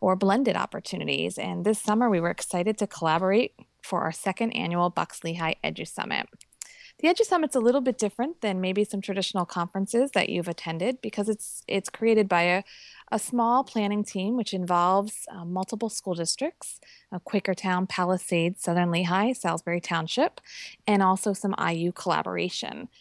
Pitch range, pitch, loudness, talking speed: 180-225 Hz, 195 Hz, -27 LUFS, 160 wpm